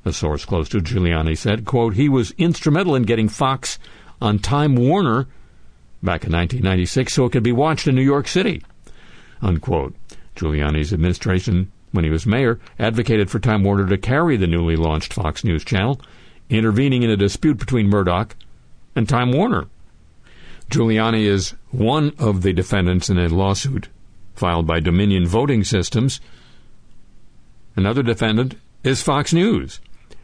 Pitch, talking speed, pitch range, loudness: 105 Hz, 150 wpm, 90-125 Hz, -19 LUFS